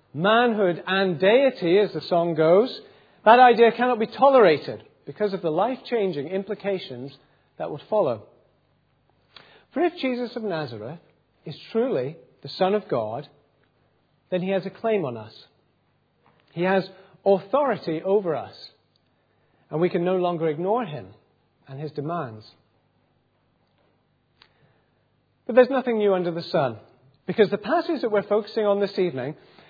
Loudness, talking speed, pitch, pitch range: -23 LUFS, 140 wpm, 190 Hz, 155-215 Hz